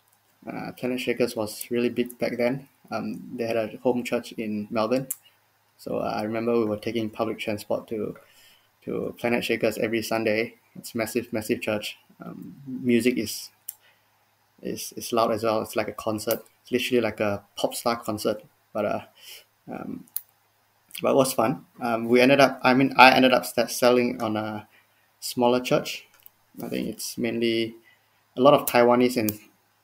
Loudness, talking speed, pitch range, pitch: -25 LUFS, 175 wpm, 110-125 Hz, 115 Hz